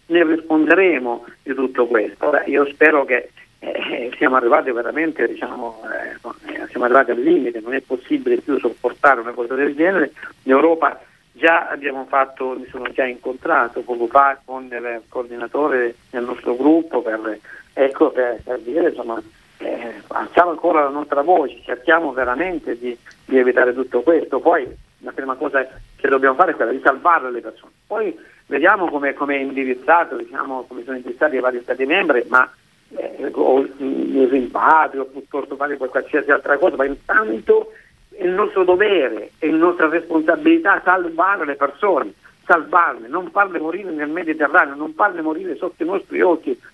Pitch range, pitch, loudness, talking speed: 130-170 Hz, 145 Hz, -18 LUFS, 165 wpm